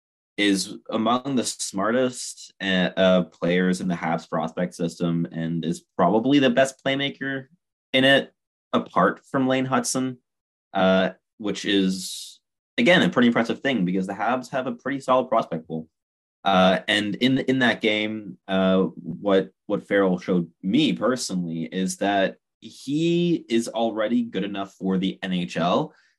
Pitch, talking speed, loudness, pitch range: 100 Hz, 145 wpm, -23 LUFS, 90-130 Hz